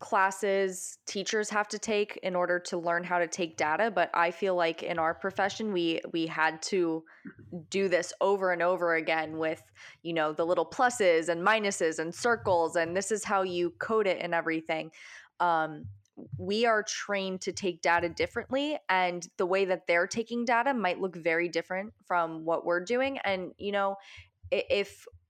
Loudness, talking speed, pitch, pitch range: -29 LUFS, 180 wpm, 180 Hz, 165-200 Hz